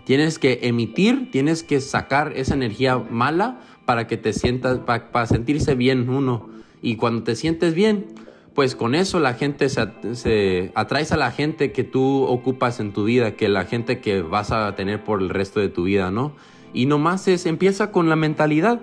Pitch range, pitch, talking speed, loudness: 115-150 Hz, 125 Hz, 195 wpm, -21 LUFS